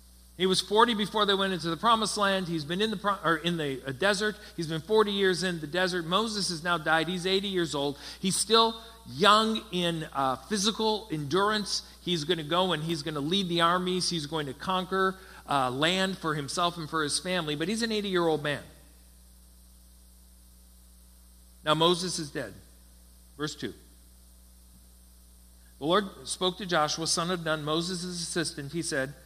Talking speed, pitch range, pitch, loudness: 185 wpm, 135-190 Hz, 170 Hz, -28 LUFS